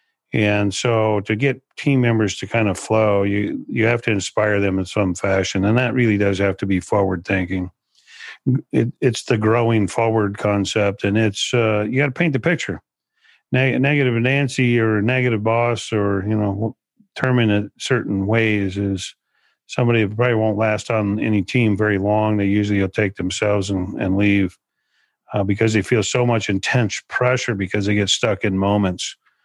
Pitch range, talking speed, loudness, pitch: 100-120 Hz, 180 wpm, -19 LUFS, 105 Hz